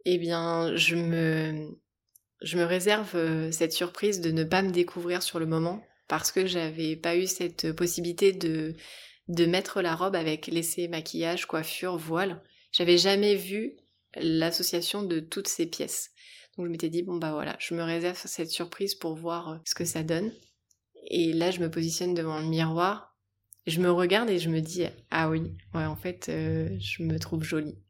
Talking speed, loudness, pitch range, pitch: 185 wpm, -28 LUFS, 160-180 Hz, 170 Hz